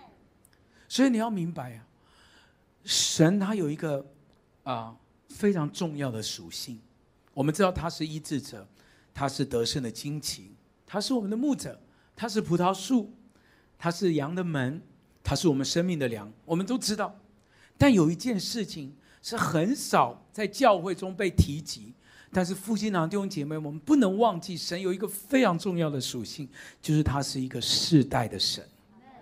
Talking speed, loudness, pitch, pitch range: 240 characters per minute, -28 LUFS, 165 Hz, 140-200 Hz